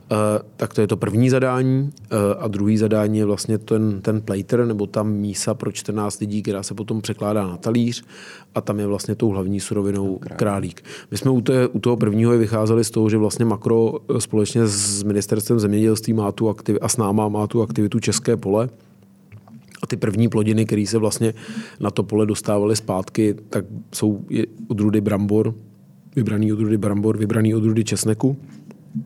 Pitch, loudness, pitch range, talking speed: 110 Hz, -20 LUFS, 105-115 Hz, 175 wpm